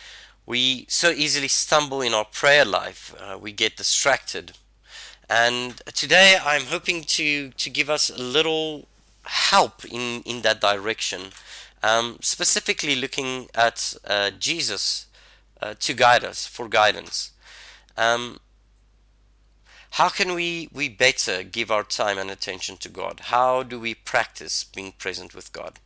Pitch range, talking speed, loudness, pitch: 110-150 Hz, 140 wpm, -21 LUFS, 125 Hz